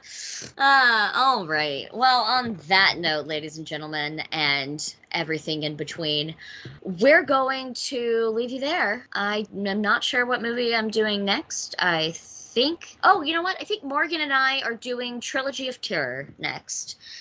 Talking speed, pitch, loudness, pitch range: 160 wpm, 230 Hz, -23 LUFS, 160-265 Hz